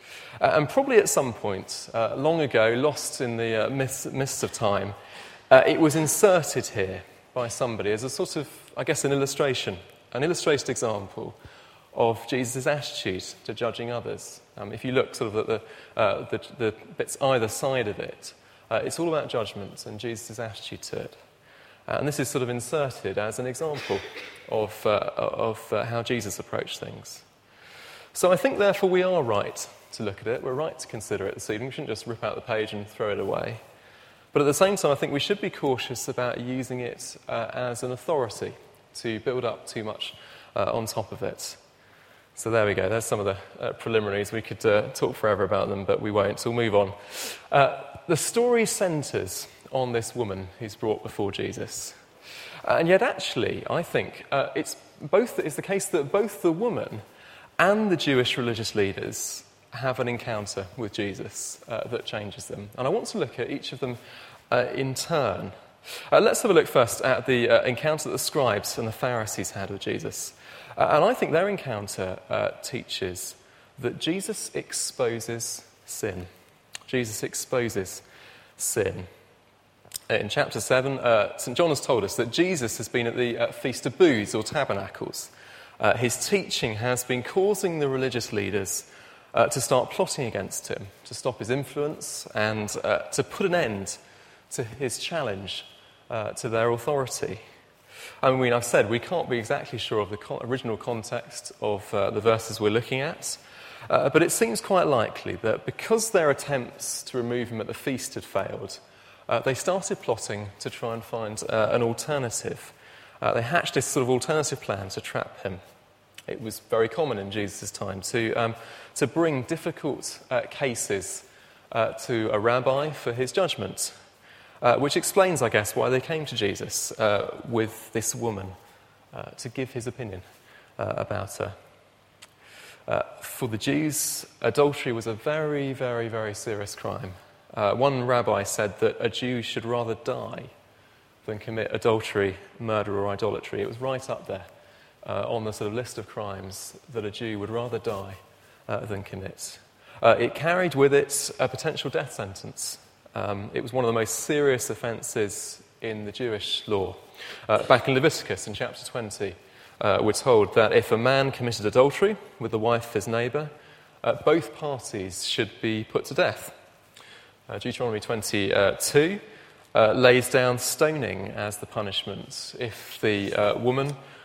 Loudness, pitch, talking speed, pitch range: -26 LUFS, 120 Hz, 180 wpm, 110-140 Hz